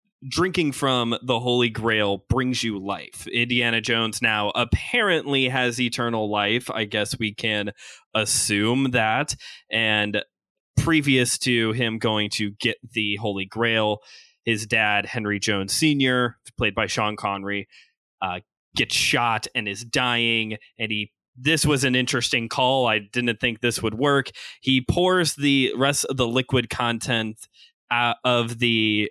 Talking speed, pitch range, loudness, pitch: 145 wpm, 110-130 Hz, -22 LUFS, 120 Hz